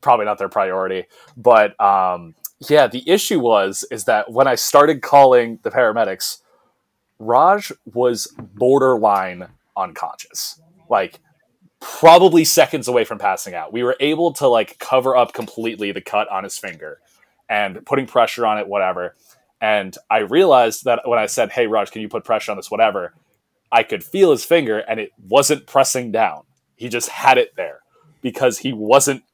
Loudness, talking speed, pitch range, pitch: -17 LUFS, 170 wpm, 115-155 Hz, 130 Hz